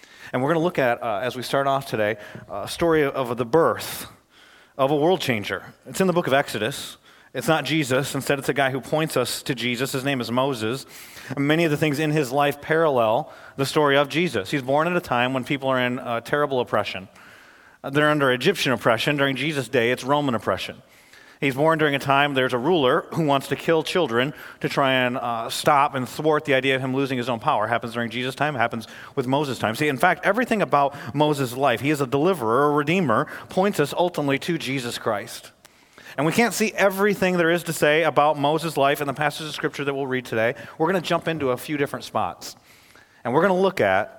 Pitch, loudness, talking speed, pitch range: 140 Hz, -22 LUFS, 230 wpm, 130-155 Hz